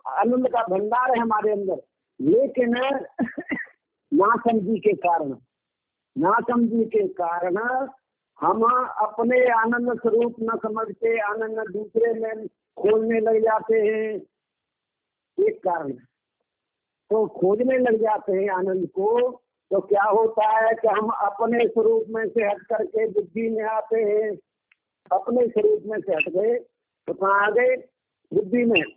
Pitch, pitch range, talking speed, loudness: 225 Hz, 210-245 Hz, 130 wpm, -23 LUFS